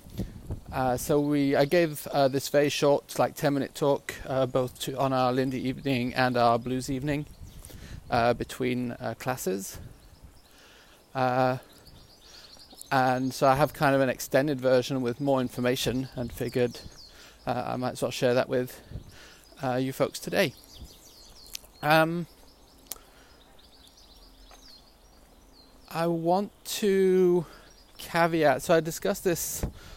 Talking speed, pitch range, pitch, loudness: 130 wpm, 120-145 Hz, 130 Hz, -27 LUFS